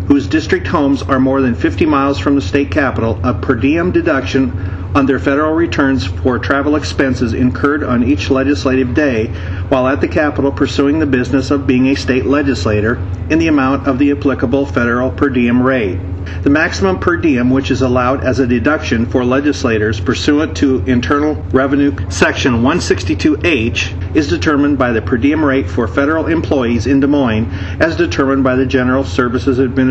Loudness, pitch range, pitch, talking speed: -13 LUFS, 115-140 Hz, 130 Hz, 175 wpm